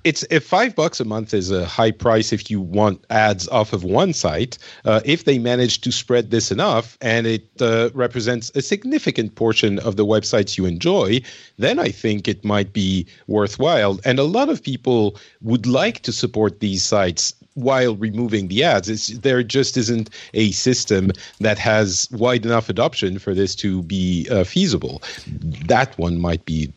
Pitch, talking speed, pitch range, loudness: 110 Hz, 180 wpm, 100-125 Hz, -19 LUFS